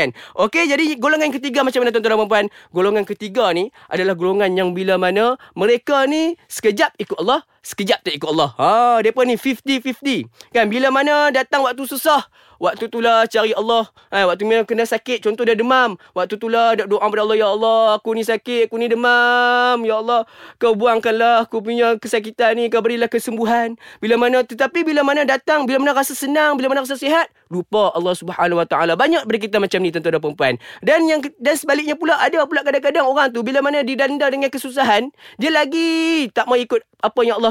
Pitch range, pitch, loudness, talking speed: 220-275 Hz, 235 Hz, -17 LUFS, 195 wpm